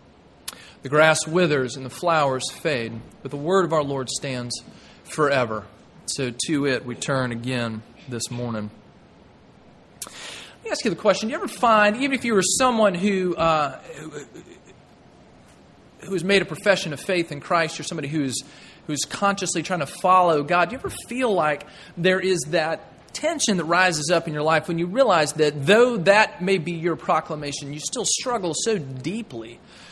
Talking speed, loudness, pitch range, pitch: 175 wpm, -22 LUFS, 145-195 Hz, 165 Hz